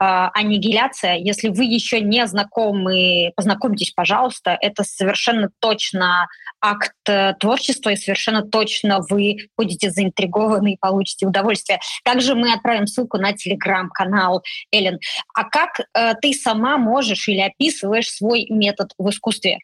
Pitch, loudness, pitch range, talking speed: 205 Hz, -18 LUFS, 195-225 Hz, 130 wpm